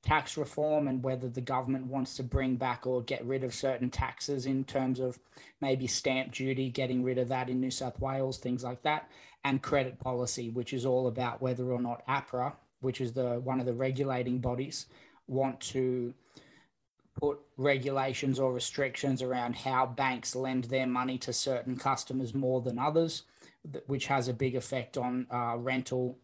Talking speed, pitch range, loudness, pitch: 180 wpm, 125-135 Hz, -33 LUFS, 130 Hz